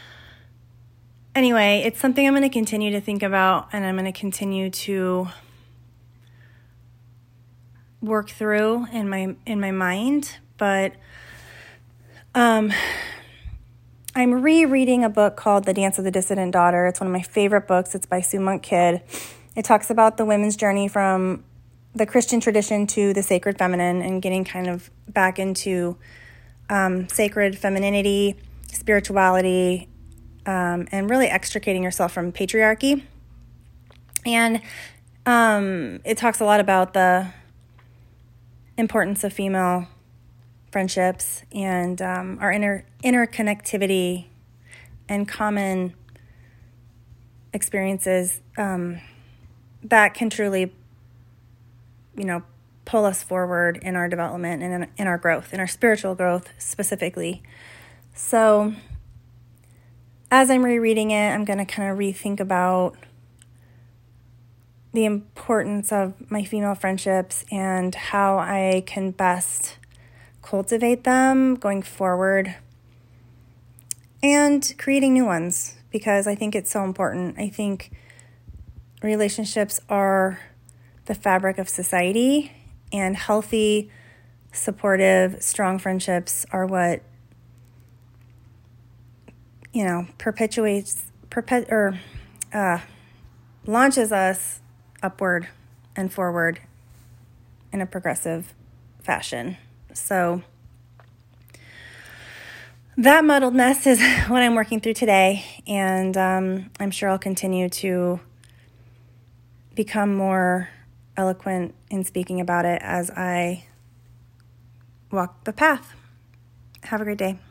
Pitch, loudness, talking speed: 185 Hz, -21 LUFS, 110 wpm